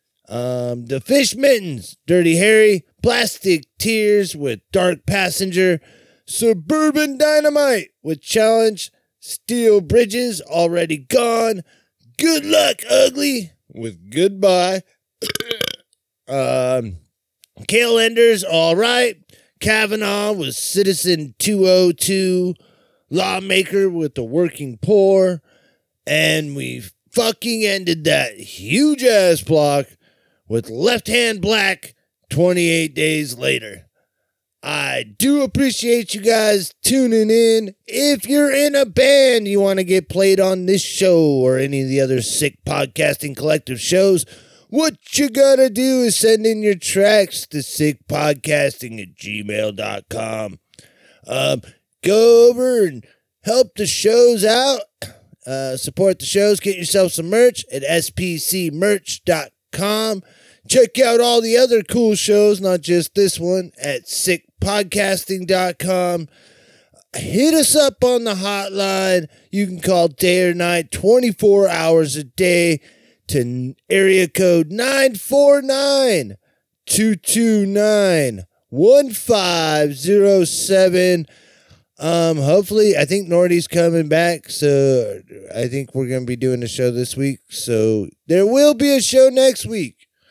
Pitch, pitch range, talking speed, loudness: 190 Hz, 155-225 Hz, 115 wpm, -16 LUFS